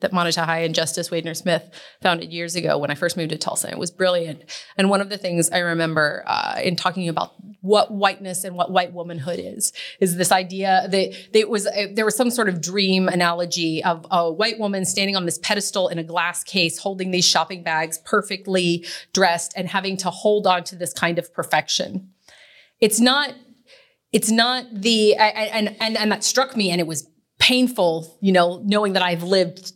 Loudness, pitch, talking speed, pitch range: -20 LUFS, 185 Hz, 205 wpm, 170-205 Hz